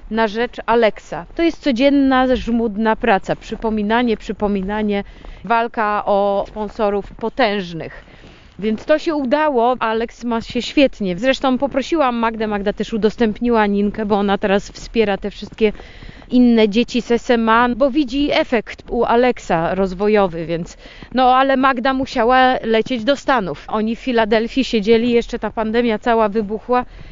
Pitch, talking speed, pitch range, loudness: 230 Hz, 135 wpm, 215-255 Hz, -17 LUFS